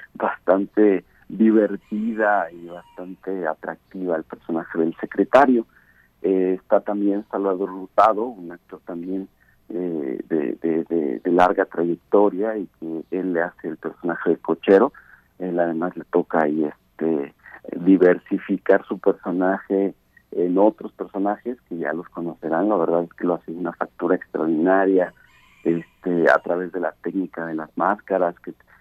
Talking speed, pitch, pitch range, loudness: 140 wpm, 90 Hz, 85-100 Hz, -22 LUFS